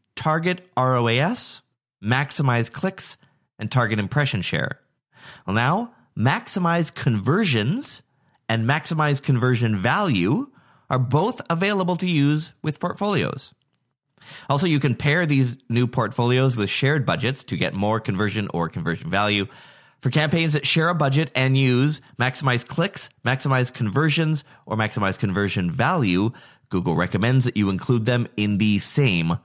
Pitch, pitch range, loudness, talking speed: 130 Hz, 115-150 Hz, -22 LUFS, 130 wpm